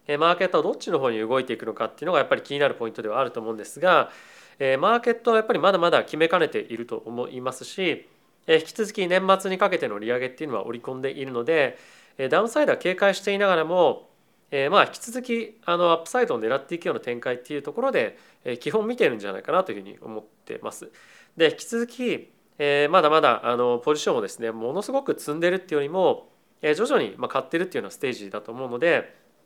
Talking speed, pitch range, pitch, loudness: 470 characters per minute, 130-220 Hz, 165 Hz, -24 LUFS